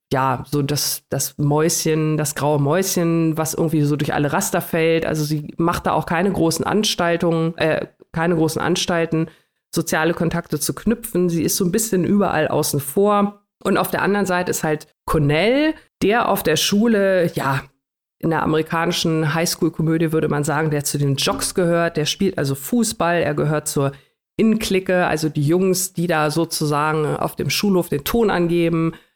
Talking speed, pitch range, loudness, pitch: 175 wpm, 155-185 Hz, -19 LUFS, 165 Hz